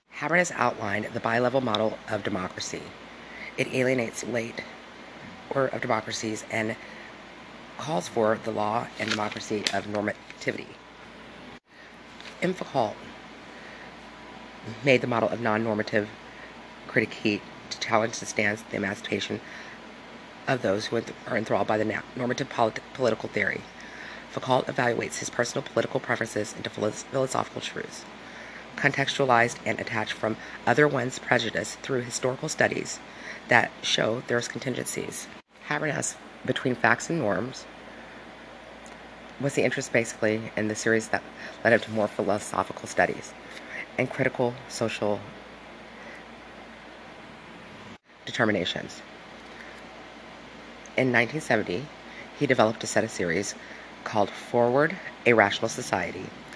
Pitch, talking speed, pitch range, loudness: 115 Hz, 110 wpm, 110-125 Hz, -27 LUFS